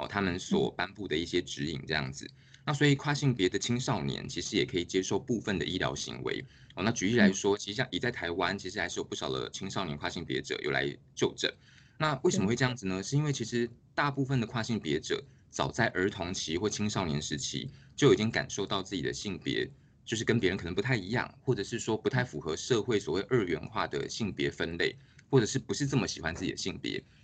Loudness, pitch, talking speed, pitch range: -31 LUFS, 110 Hz, 350 characters per minute, 90-135 Hz